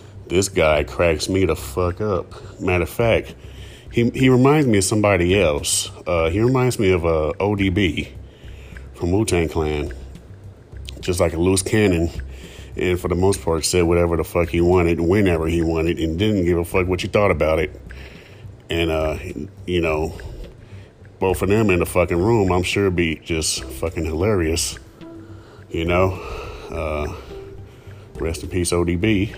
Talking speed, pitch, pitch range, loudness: 165 wpm, 90 Hz, 85-100 Hz, -20 LUFS